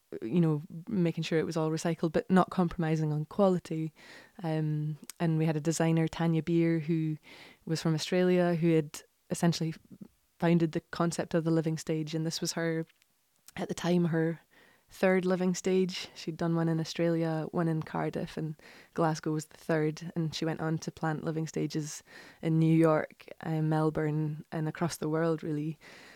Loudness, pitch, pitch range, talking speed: -31 LUFS, 165 Hz, 160-170 Hz, 175 wpm